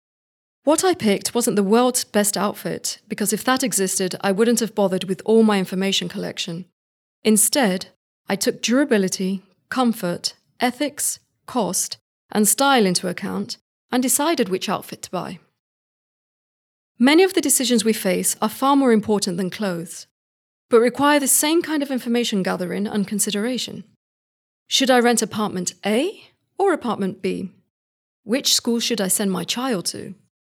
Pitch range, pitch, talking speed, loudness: 195-255 Hz, 215 Hz, 150 wpm, -20 LUFS